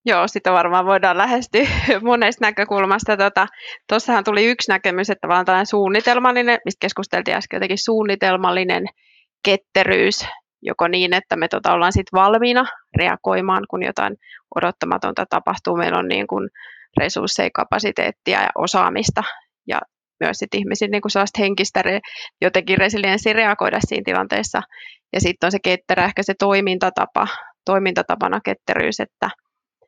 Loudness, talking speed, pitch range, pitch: -18 LUFS, 135 wpm, 190-215 Hz, 195 Hz